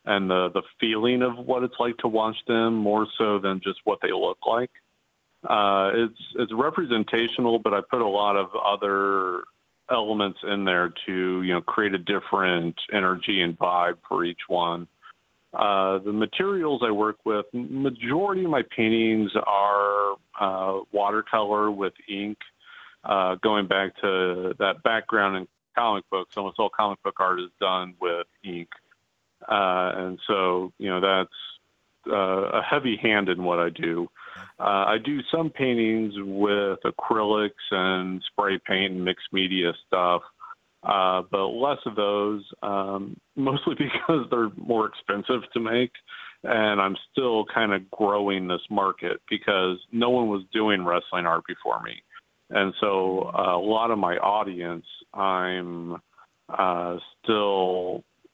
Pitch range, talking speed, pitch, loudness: 90-110 Hz, 150 wpm, 100 Hz, -25 LUFS